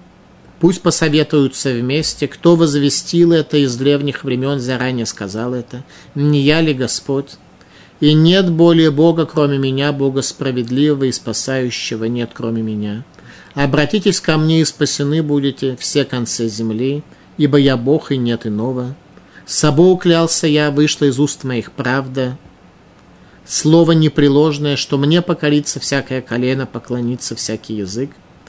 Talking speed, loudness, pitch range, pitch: 135 wpm, -15 LUFS, 125-150 Hz, 140 Hz